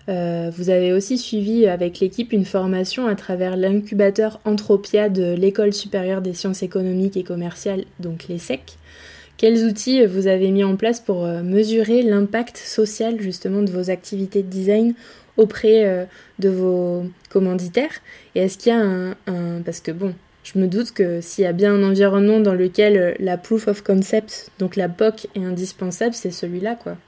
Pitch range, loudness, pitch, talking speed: 185-215 Hz, -20 LUFS, 195 Hz, 175 wpm